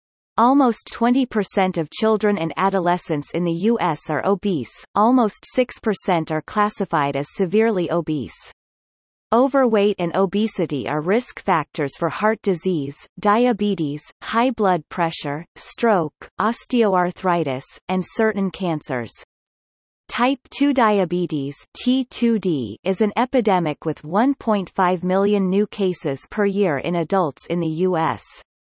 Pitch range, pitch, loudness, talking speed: 165-215 Hz, 190 Hz, -21 LUFS, 115 wpm